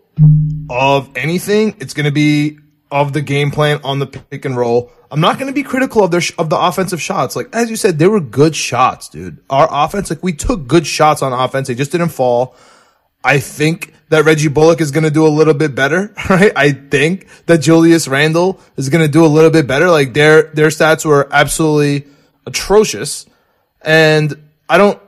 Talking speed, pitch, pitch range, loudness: 200 wpm, 155 Hz, 145-170 Hz, -12 LUFS